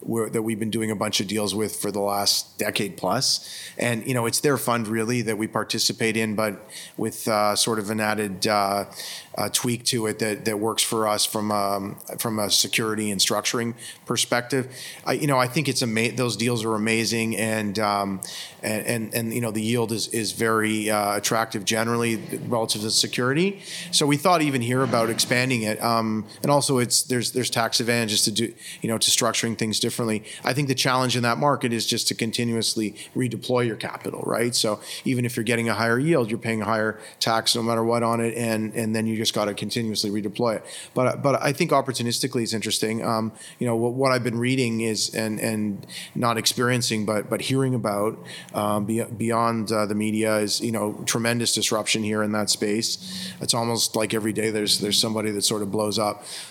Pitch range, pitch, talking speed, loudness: 110-120 Hz, 115 Hz, 215 wpm, -23 LUFS